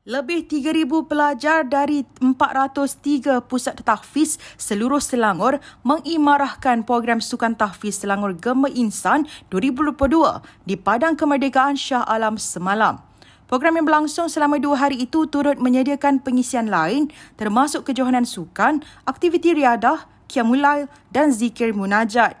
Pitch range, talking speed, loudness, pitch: 235-295 Hz, 115 wpm, -19 LUFS, 270 Hz